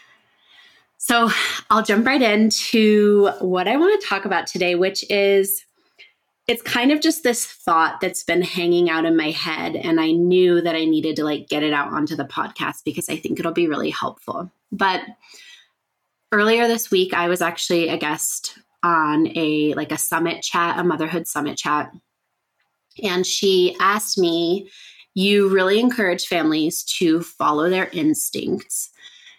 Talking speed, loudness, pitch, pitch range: 160 wpm, -19 LUFS, 185 Hz, 165-215 Hz